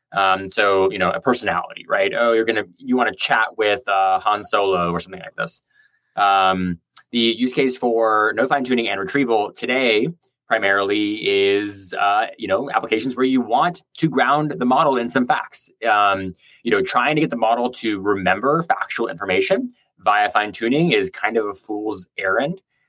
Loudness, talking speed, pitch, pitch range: -19 LUFS, 185 wpm, 110 Hz, 100-130 Hz